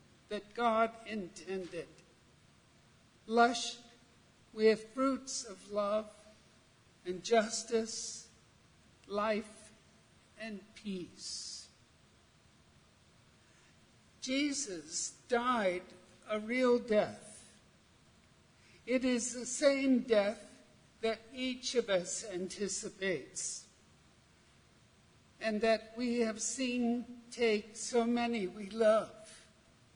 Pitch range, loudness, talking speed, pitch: 210-240 Hz, -35 LUFS, 75 wpm, 225 Hz